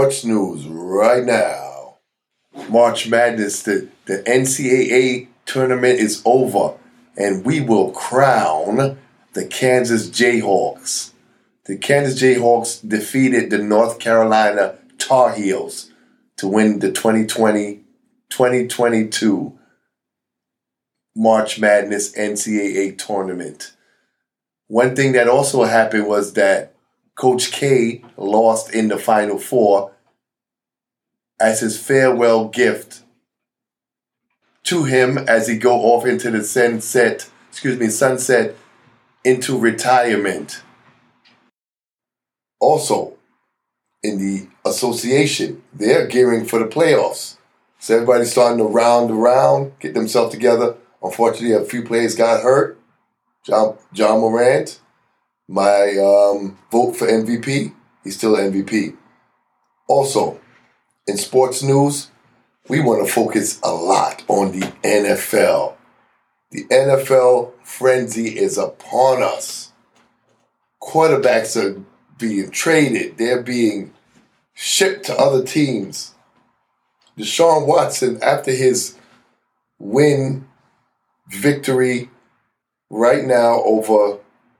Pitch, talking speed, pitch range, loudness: 115 Hz, 100 wpm, 105-130 Hz, -16 LUFS